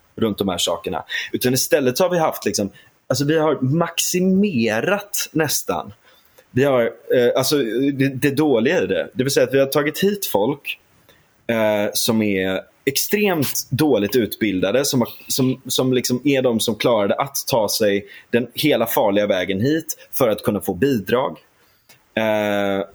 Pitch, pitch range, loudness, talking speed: 130 Hz, 110-160 Hz, -19 LUFS, 165 wpm